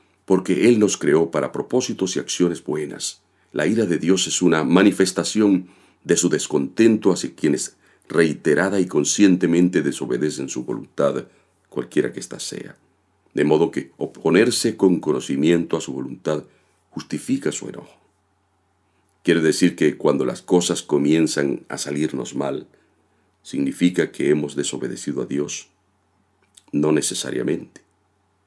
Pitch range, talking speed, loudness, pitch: 85-100 Hz, 130 wpm, -20 LUFS, 95 Hz